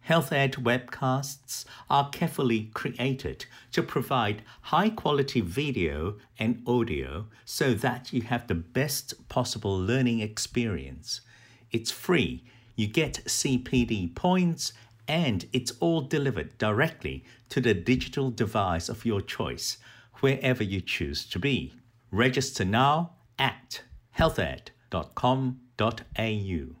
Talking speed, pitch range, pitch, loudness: 105 wpm, 110-135 Hz, 120 Hz, -28 LUFS